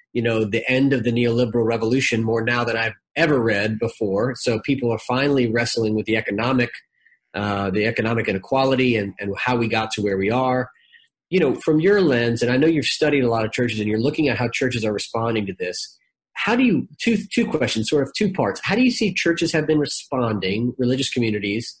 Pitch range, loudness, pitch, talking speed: 110-145 Hz, -20 LUFS, 120 Hz, 220 wpm